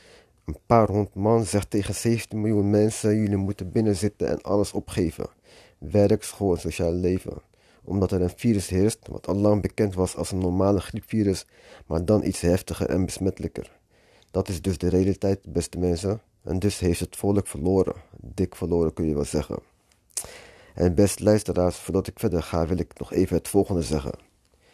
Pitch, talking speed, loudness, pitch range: 95 Hz, 175 wpm, -25 LUFS, 90-105 Hz